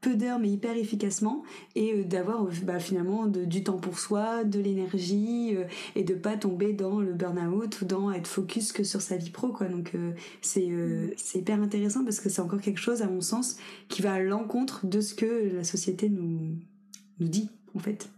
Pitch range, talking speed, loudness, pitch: 185-215 Hz, 215 wpm, -30 LUFS, 200 Hz